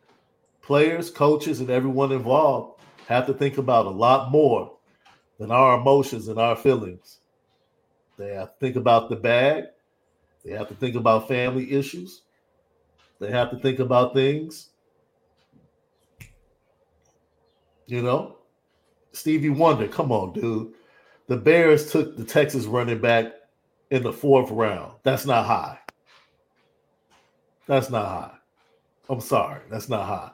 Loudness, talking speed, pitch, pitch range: -22 LUFS, 135 wpm, 125 Hz, 115-140 Hz